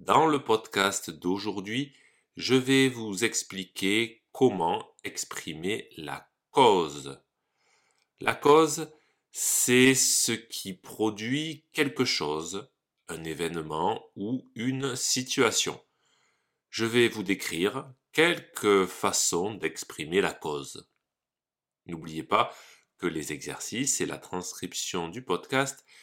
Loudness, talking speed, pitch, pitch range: -27 LUFS, 100 wpm, 115 Hz, 90-135 Hz